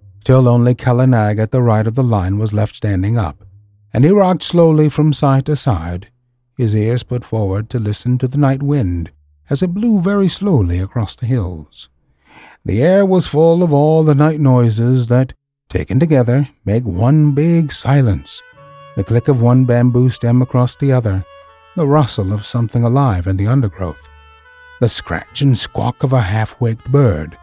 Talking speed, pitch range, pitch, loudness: 175 wpm, 105-140 Hz, 125 Hz, -14 LUFS